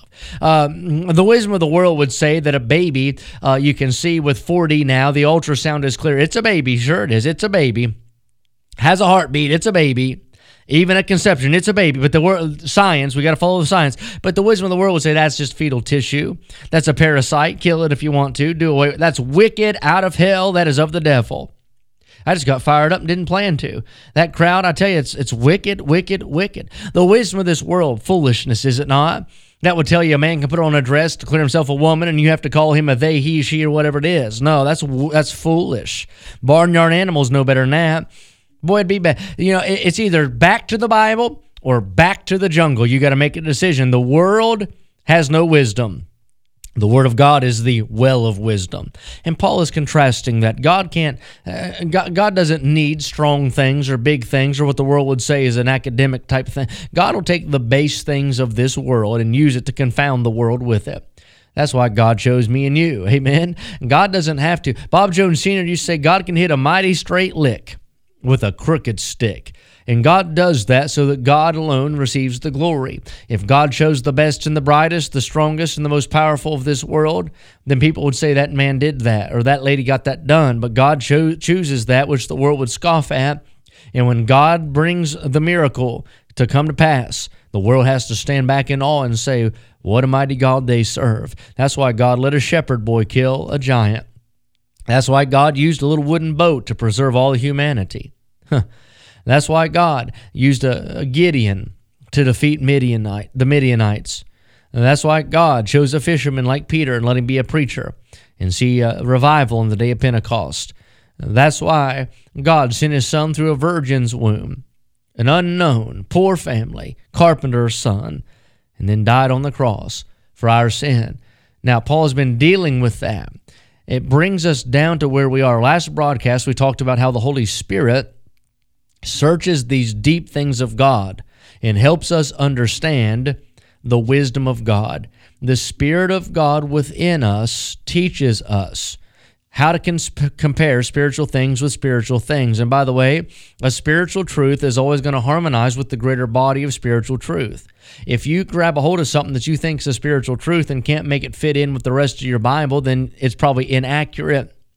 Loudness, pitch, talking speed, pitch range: -16 LUFS, 140 Hz, 205 wpm, 125-160 Hz